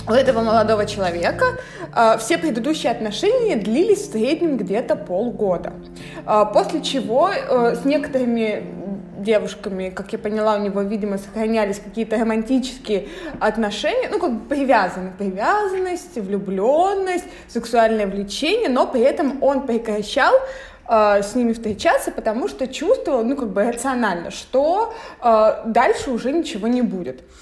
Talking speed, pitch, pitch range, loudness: 135 wpm, 230 Hz, 210-285 Hz, -20 LUFS